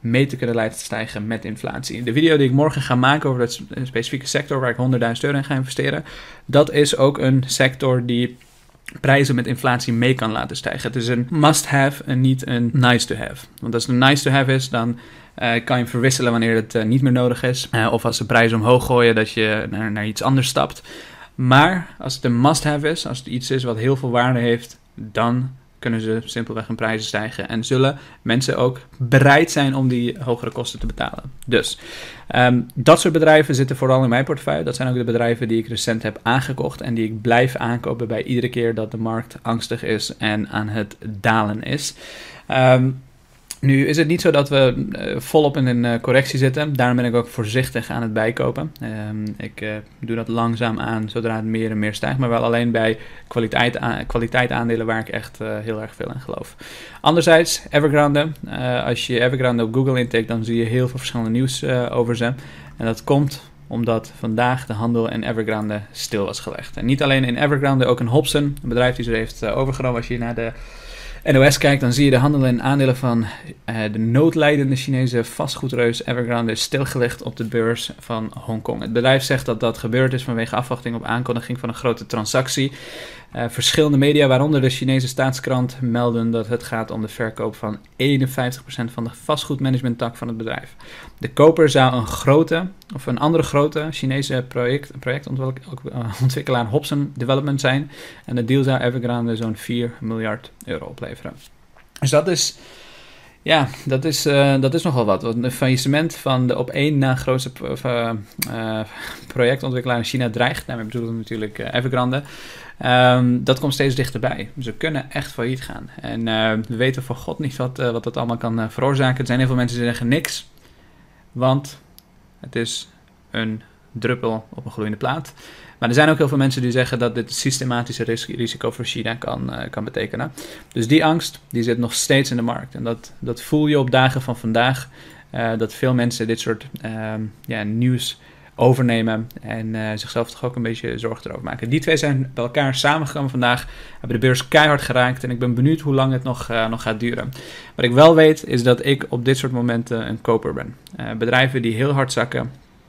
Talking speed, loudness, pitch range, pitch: 200 wpm, -19 LUFS, 115-135 Hz, 125 Hz